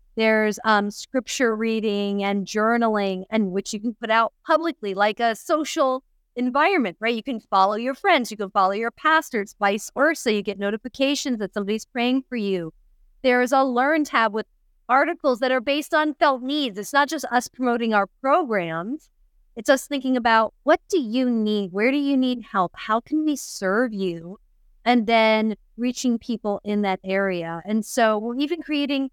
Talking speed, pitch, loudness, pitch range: 180 wpm, 230 Hz, -22 LUFS, 210-270 Hz